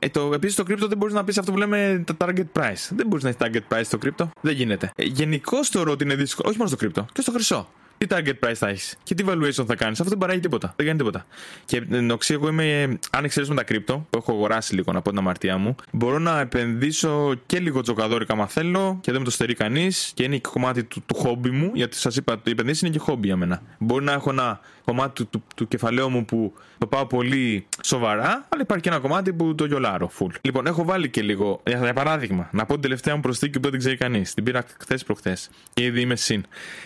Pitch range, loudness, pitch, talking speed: 115-160 Hz, -23 LUFS, 130 Hz, 250 wpm